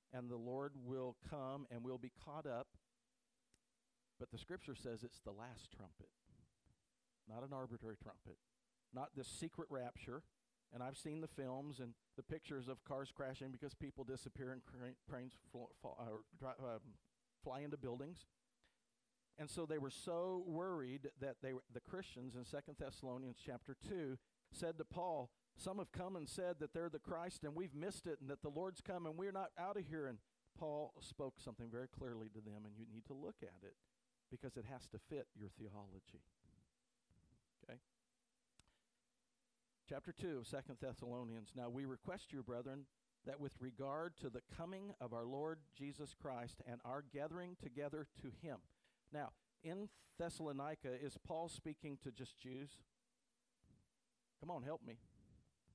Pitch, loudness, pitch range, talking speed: 135 Hz, -51 LUFS, 125-155 Hz, 165 wpm